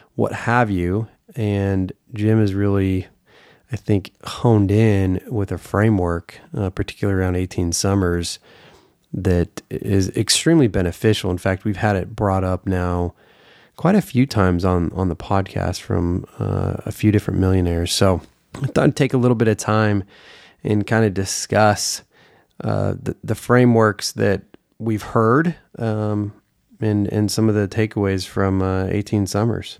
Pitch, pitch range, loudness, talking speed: 105 Hz, 95-110 Hz, -20 LUFS, 155 wpm